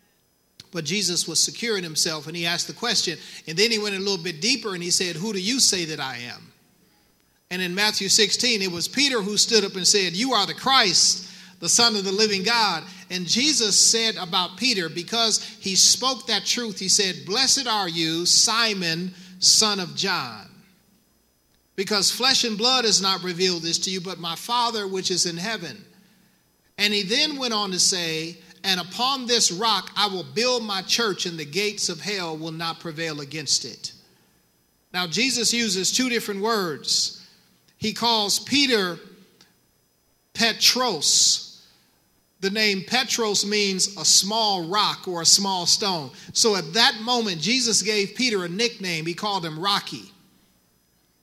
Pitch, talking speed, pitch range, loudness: 195 Hz, 170 wpm, 175-220 Hz, -21 LUFS